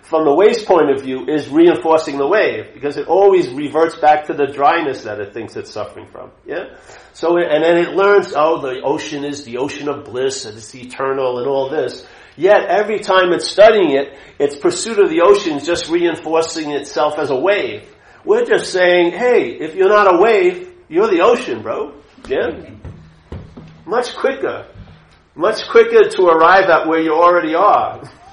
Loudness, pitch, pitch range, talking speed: -14 LUFS, 165 Hz, 145-210 Hz, 185 wpm